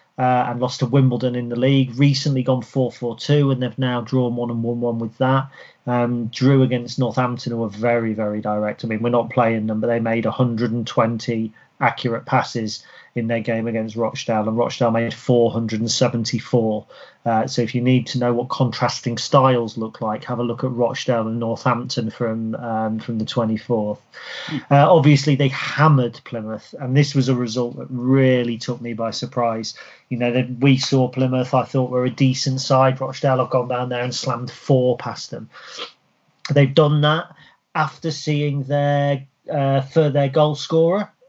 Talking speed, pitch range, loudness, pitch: 180 wpm, 115-135 Hz, -20 LUFS, 125 Hz